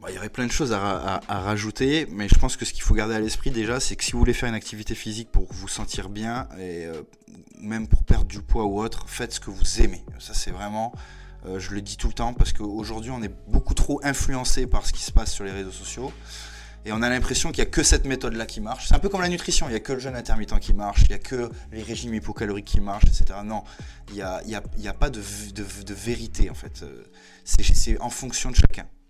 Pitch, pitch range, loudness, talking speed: 105 Hz, 95-120 Hz, -27 LUFS, 270 wpm